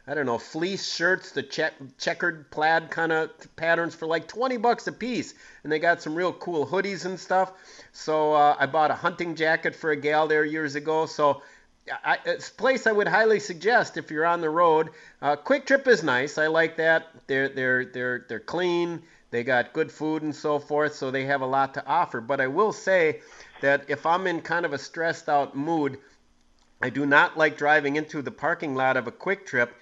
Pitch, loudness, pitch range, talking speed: 155 Hz, -25 LUFS, 145-175 Hz, 215 wpm